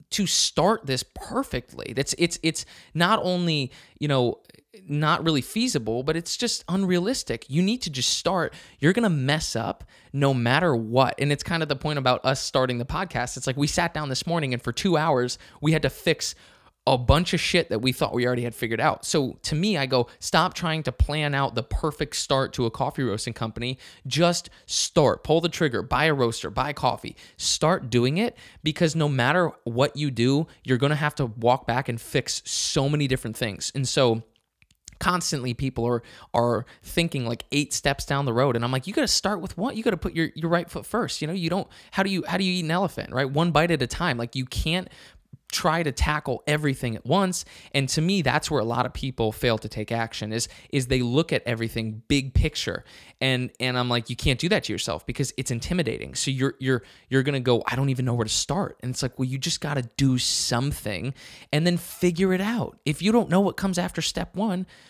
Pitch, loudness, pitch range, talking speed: 140 Hz, -25 LUFS, 125-165 Hz, 230 wpm